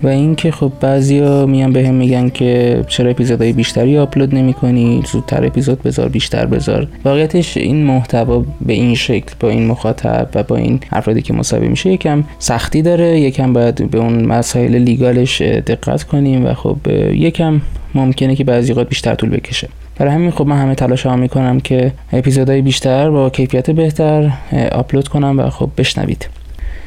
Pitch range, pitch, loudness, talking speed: 120-145 Hz, 130 Hz, -13 LUFS, 165 wpm